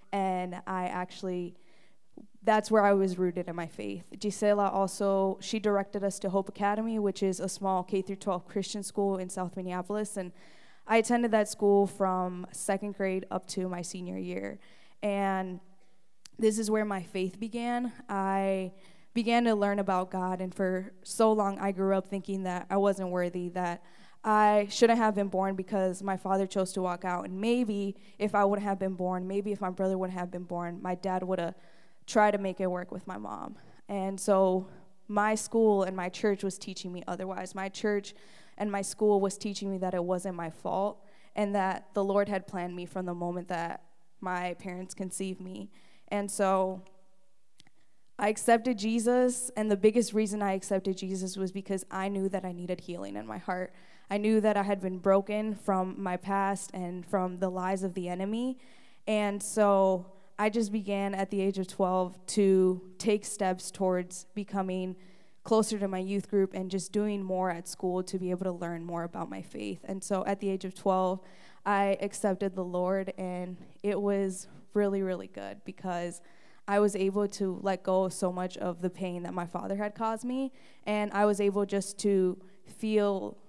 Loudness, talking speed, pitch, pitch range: -31 LUFS, 190 wpm, 195 Hz, 185-205 Hz